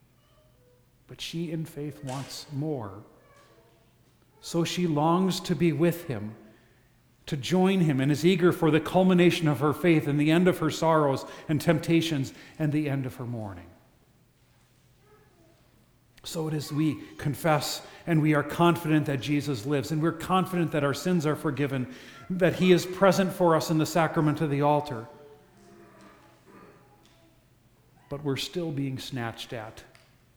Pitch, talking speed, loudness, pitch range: 150 Hz, 150 wpm, -26 LUFS, 130-165 Hz